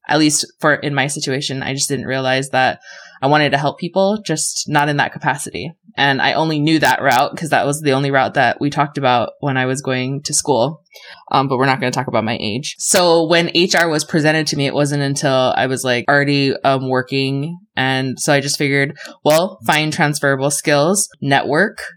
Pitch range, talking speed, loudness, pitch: 130-155 Hz, 215 wpm, -16 LUFS, 140 Hz